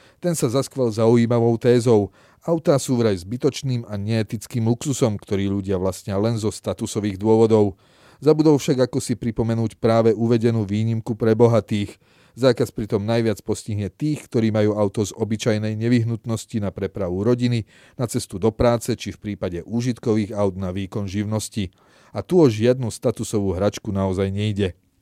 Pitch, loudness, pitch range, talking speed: 110 Hz, -21 LUFS, 105-120 Hz, 150 wpm